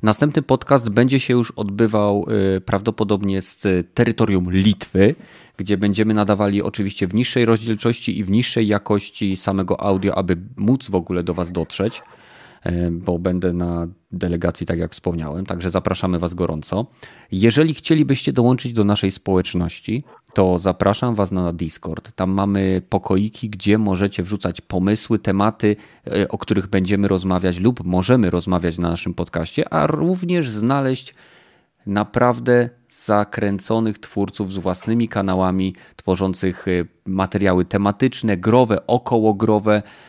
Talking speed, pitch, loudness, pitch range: 125 wpm, 100 Hz, -19 LUFS, 95-115 Hz